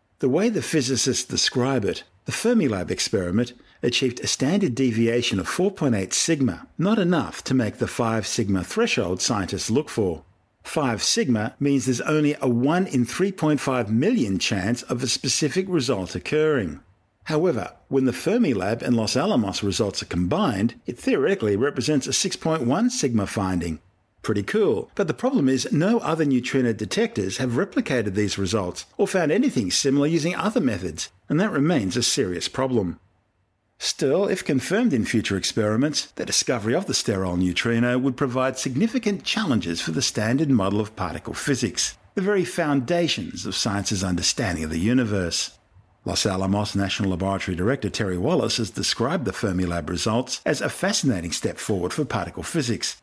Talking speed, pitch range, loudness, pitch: 155 wpm, 100-145 Hz, -23 LUFS, 120 Hz